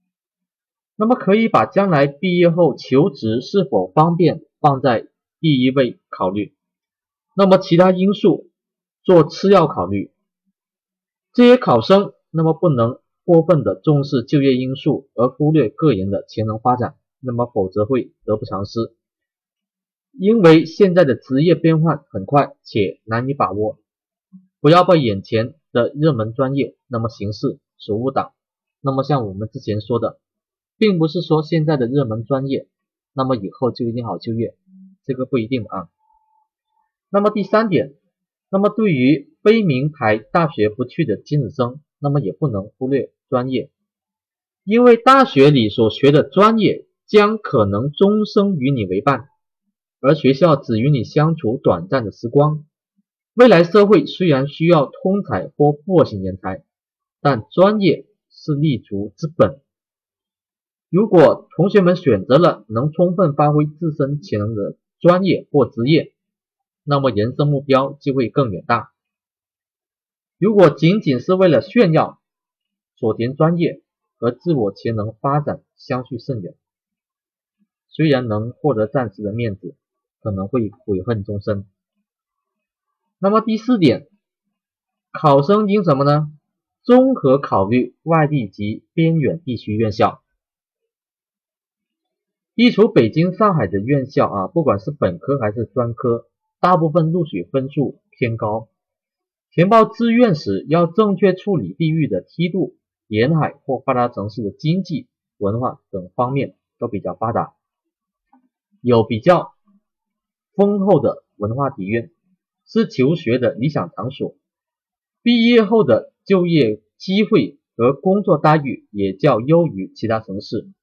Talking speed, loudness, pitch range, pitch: 210 characters per minute, -17 LUFS, 125-195 Hz, 155 Hz